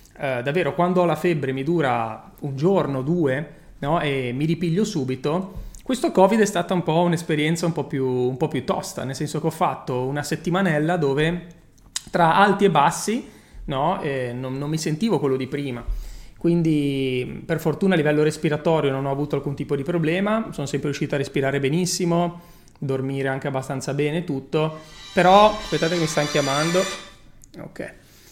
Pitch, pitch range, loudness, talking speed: 155 Hz, 140-175 Hz, -22 LUFS, 175 wpm